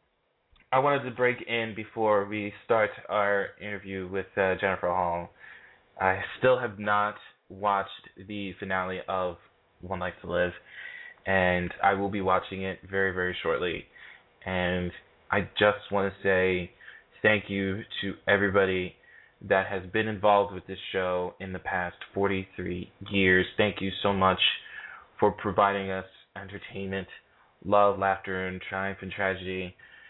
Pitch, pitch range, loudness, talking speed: 95 Hz, 95-100 Hz, -28 LUFS, 140 wpm